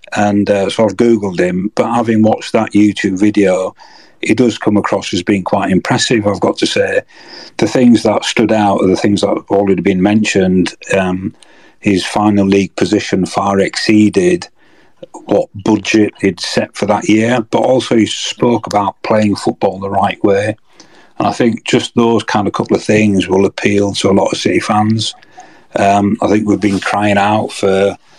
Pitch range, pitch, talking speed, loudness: 100-110 Hz, 105 Hz, 190 wpm, -13 LUFS